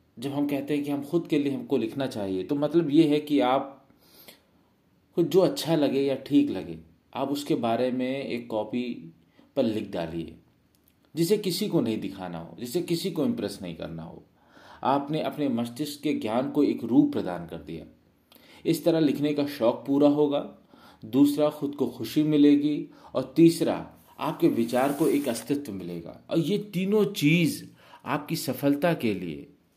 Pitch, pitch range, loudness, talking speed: 140 Hz, 115-155 Hz, -26 LUFS, 175 wpm